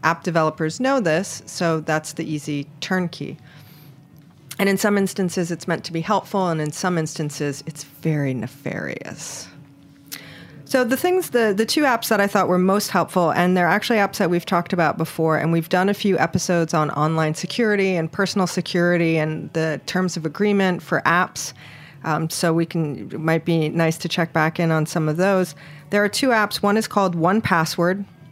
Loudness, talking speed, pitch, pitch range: -21 LUFS, 195 wpm, 170 Hz, 155-195 Hz